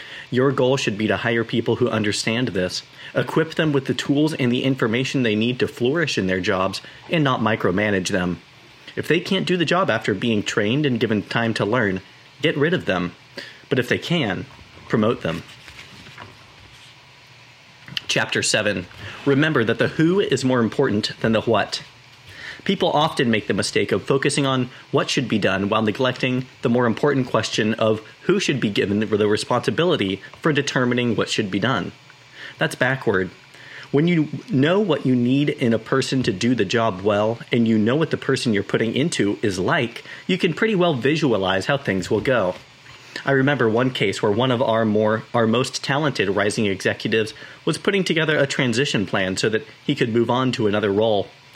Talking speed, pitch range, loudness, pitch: 185 wpm, 110-140 Hz, -21 LUFS, 125 Hz